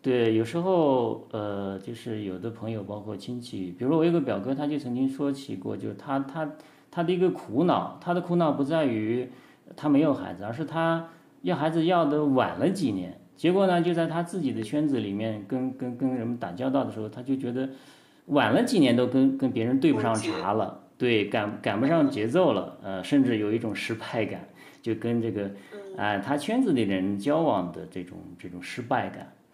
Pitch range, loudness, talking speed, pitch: 110-155 Hz, -27 LUFS, 295 characters per minute, 130 Hz